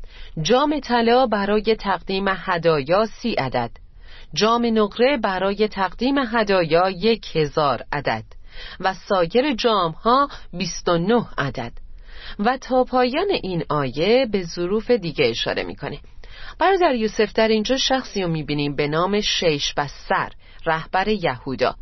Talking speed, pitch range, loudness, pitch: 130 wpm, 160-235 Hz, -21 LUFS, 195 Hz